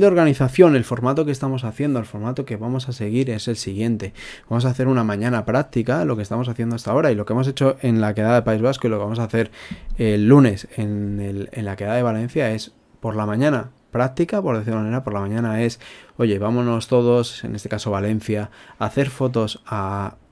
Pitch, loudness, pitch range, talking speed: 115 Hz, -21 LUFS, 110-130 Hz, 230 wpm